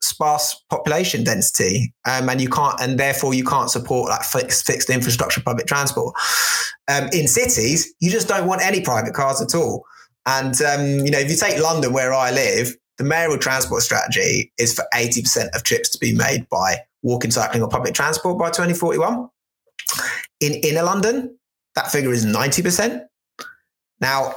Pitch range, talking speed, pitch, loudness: 125-170 Hz, 170 wpm, 140 Hz, -19 LUFS